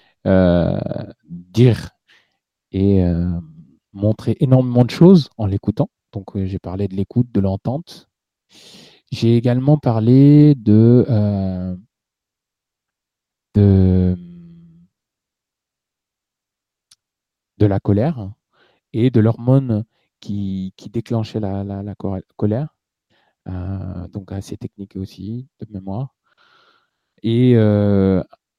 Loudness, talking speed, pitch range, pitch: -17 LUFS, 95 wpm, 95-125 Hz, 105 Hz